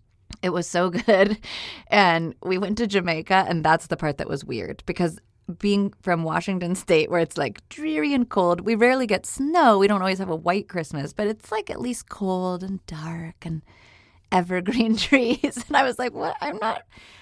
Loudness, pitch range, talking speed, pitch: -23 LUFS, 165-210 Hz, 200 wpm, 185 Hz